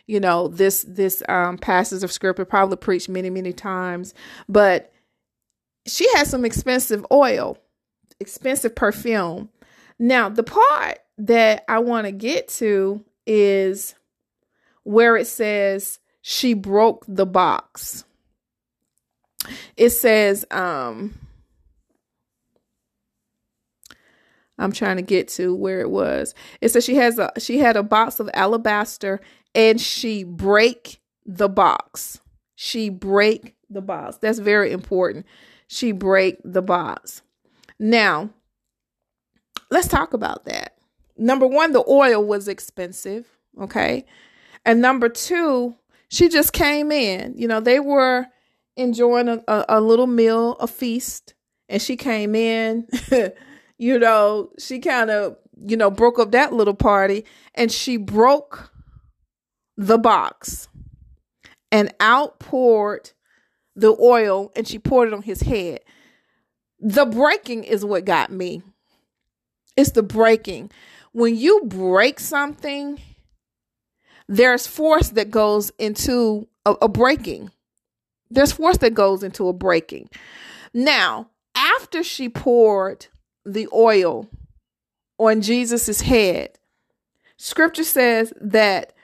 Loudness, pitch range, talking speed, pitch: -18 LUFS, 200-250 Hz, 120 wpm, 225 Hz